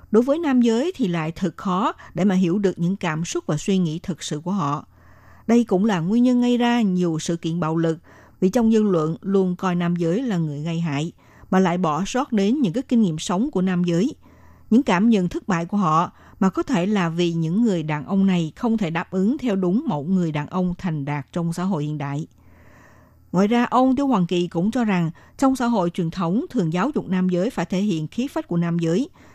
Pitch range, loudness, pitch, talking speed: 165-220 Hz, -22 LUFS, 180 Hz, 245 wpm